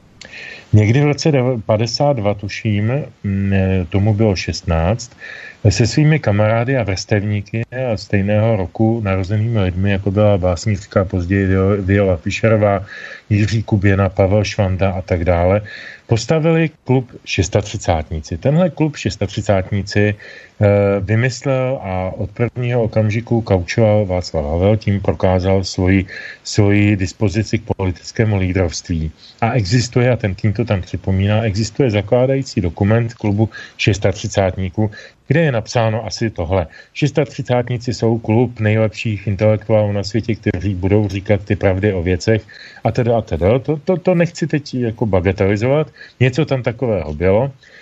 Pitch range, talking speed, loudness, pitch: 100-120 Hz, 125 wpm, -17 LUFS, 105 Hz